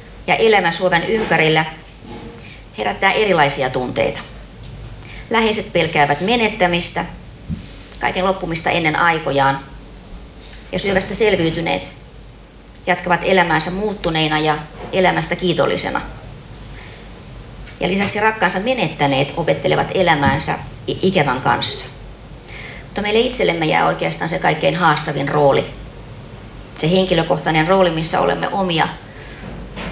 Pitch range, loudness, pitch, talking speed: 130-185 Hz, -16 LUFS, 155 Hz, 90 wpm